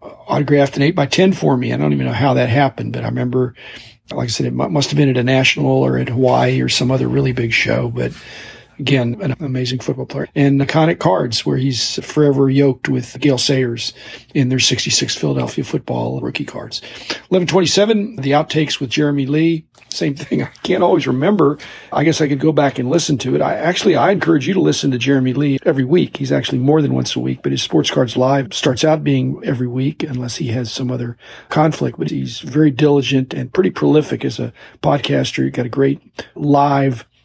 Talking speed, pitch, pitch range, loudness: 210 wpm, 135 Hz, 125-145 Hz, -16 LUFS